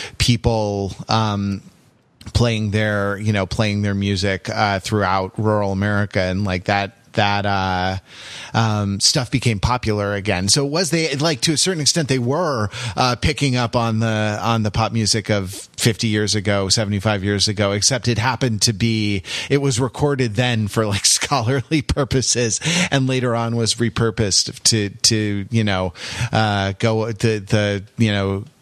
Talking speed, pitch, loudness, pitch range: 165 wpm, 110 Hz, -19 LUFS, 100-125 Hz